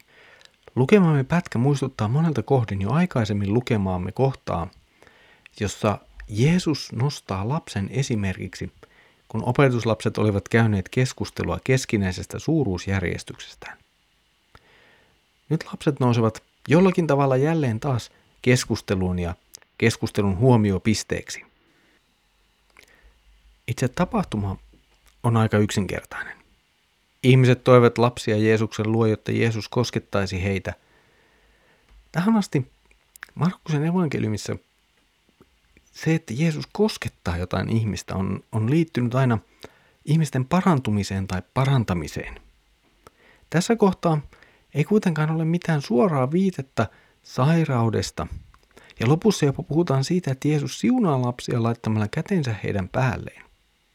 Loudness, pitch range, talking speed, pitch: -23 LUFS, 100-150 Hz, 95 wpm, 120 Hz